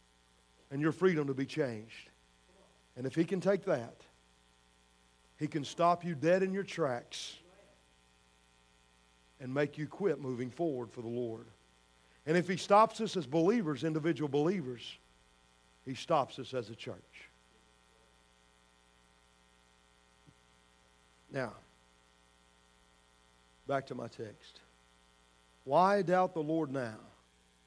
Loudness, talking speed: -34 LUFS, 115 wpm